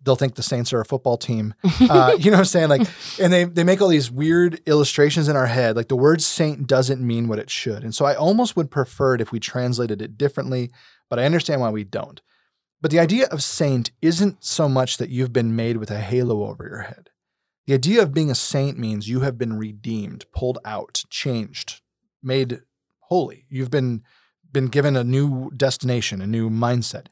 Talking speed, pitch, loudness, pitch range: 215 wpm, 130 Hz, -20 LUFS, 120-155 Hz